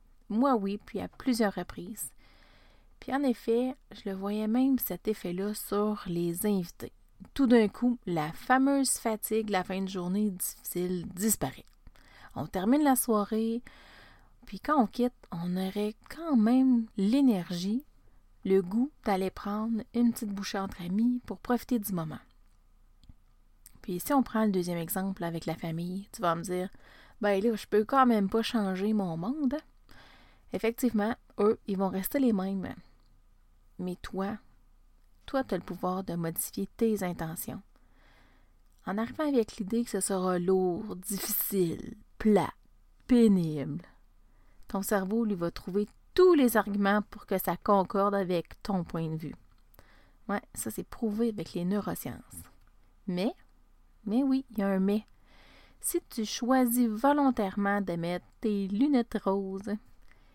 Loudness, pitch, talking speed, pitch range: -30 LUFS, 205 Hz, 150 wpm, 180-235 Hz